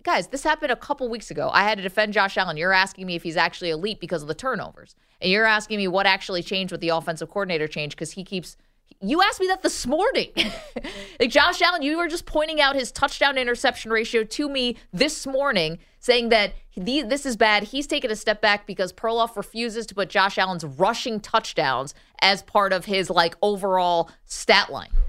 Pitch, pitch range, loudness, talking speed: 210 Hz, 185-260 Hz, -22 LUFS, 210 wpm